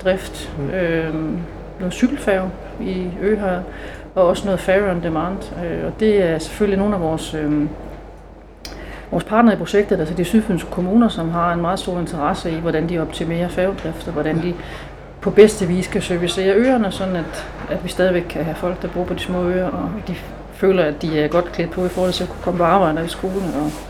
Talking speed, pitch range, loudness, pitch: 215 wpm, 165-190 Hz, -19 LUFS, 180 Hz